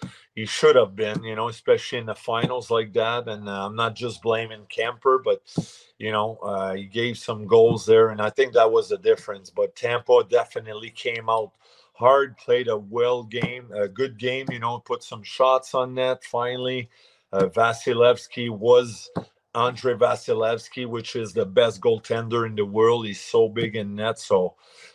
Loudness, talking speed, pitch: -23 LUFS, 180 wpm, 120 Hz